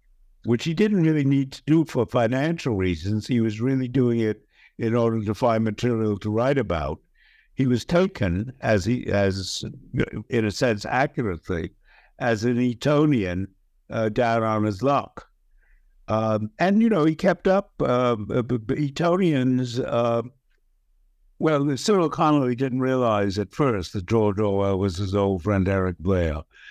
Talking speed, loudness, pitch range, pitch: 150 wpm, -23 LUFS, 100-135 Hz, 115 Hz